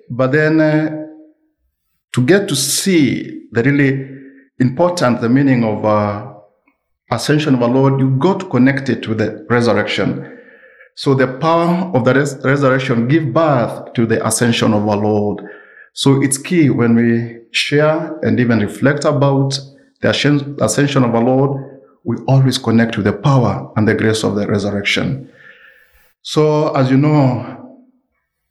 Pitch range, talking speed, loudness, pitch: 115-145 Hz, 155 wpm, -15 LUFS, 135 Hz